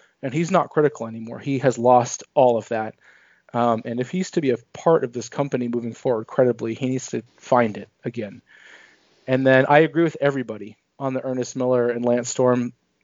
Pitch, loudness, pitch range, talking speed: 125 Hz, -22 LUFS, 120-140 Hz, 200 wpm